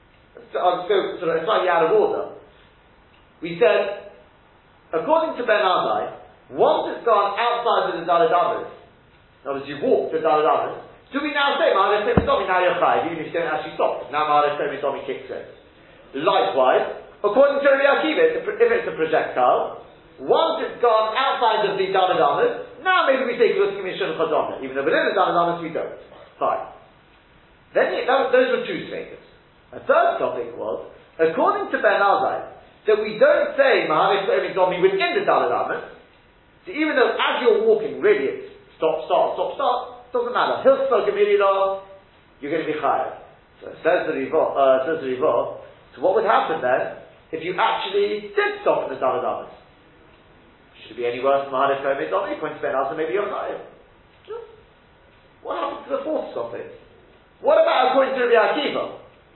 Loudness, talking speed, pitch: -21 LUFS, 170 wpm, 270 Hz